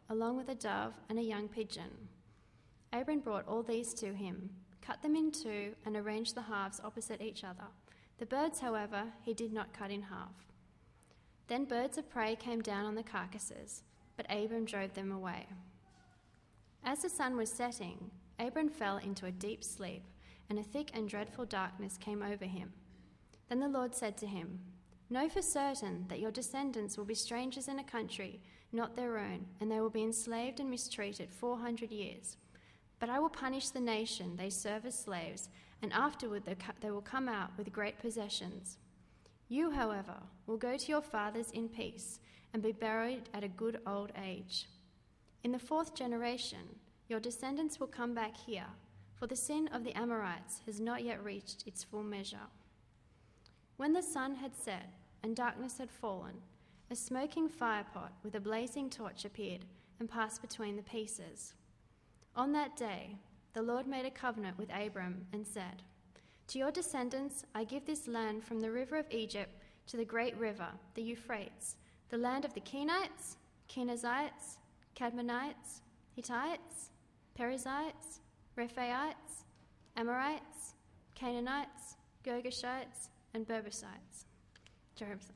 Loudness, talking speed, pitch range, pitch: -41 LUFS, 160 wpm, 205-250 Hz, 225 Hz